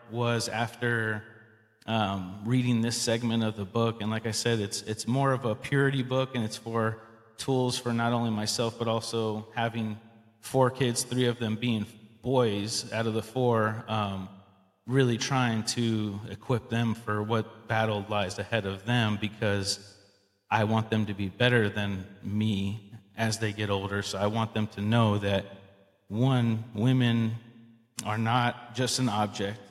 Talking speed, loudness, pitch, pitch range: 165 wpm, -29 LUFS, 110 Hz, 105-120 Hz